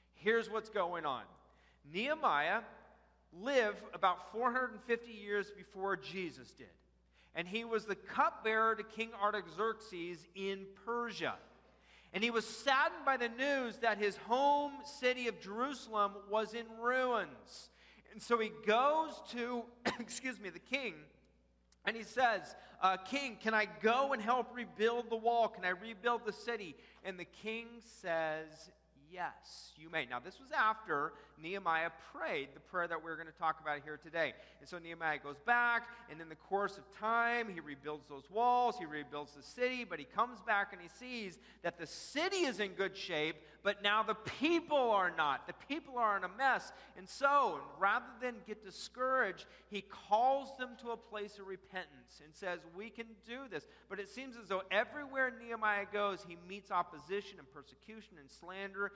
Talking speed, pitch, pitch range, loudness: 170 wpm, 210 Hz, 180-235 Hz, -37 LUFS